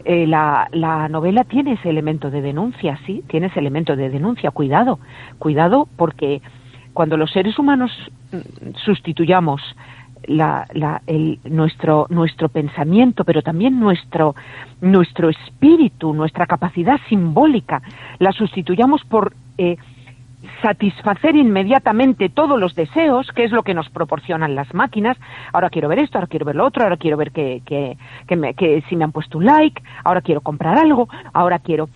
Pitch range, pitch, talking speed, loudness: 150-210 Hz, 165 Hz, 155 wpm, -17 LUFS